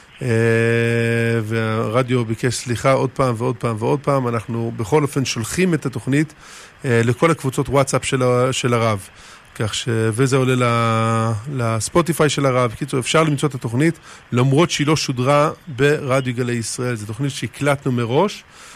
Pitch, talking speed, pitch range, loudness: 130 Hz, 145 wpm, 115-140 Hz, -19 LUFS